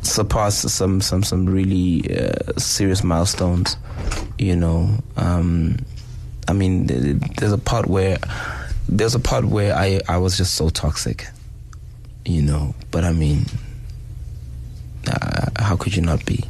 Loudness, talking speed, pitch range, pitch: -20 LUFS, 145 wpm, 90-110 Hz, 95 Hz